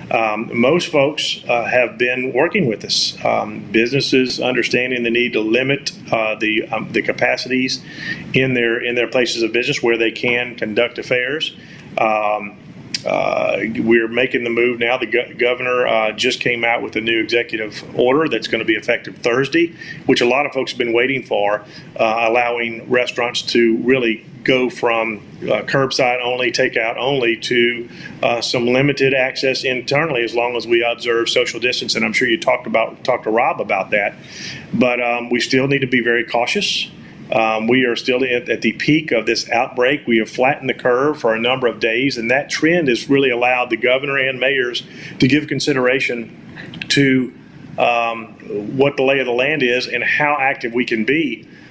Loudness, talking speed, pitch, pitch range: -17 LUFS, 185 wpm, 125 Hz, 115-130 Hz